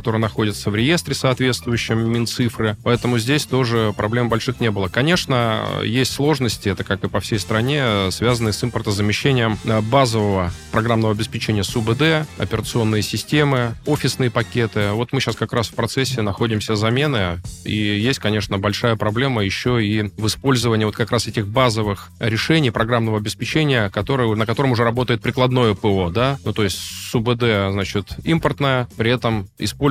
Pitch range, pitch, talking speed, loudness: 105-125 Hz, 115 Hz, 155 wpm, -19 LUFS